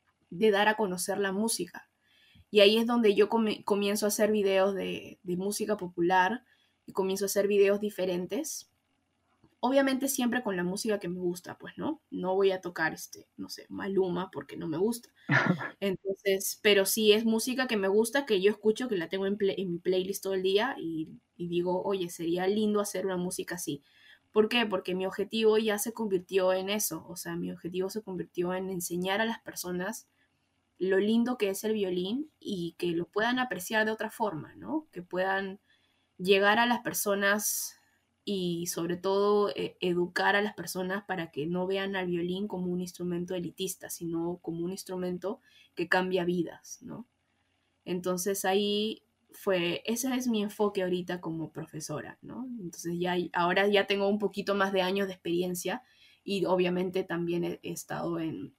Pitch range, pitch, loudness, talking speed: 180-210 Hz, 190 Hz, -30 LUFS, 185 wpm